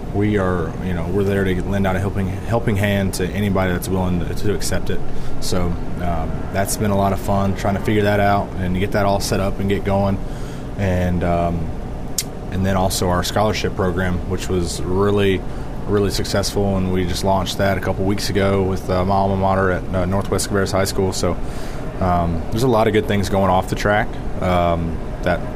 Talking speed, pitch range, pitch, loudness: 210 wpm, 90-100 Hz, 95 Hz, -20 LUFS